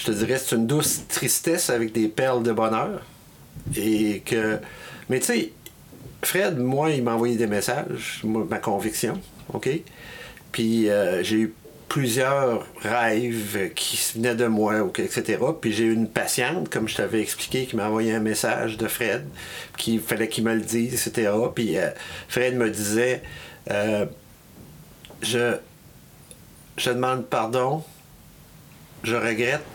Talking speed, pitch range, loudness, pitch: 150 wpm, 110-125 Hz, -24 LUFS, 115 Hz